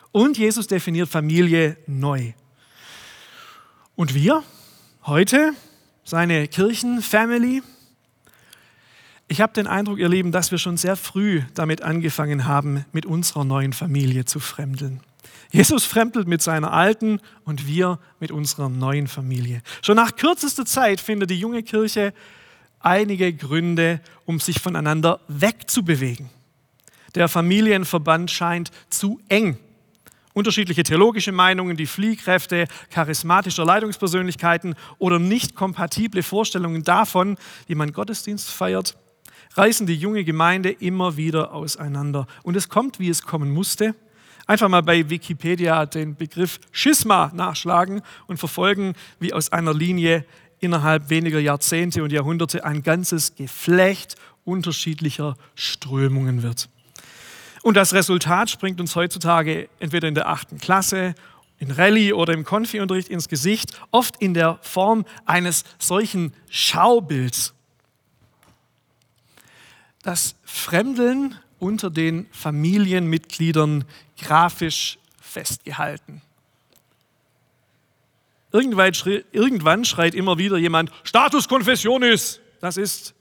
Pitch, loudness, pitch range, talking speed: 170 Hz, -20 LUFS, 155-200 Hz, 110 wpm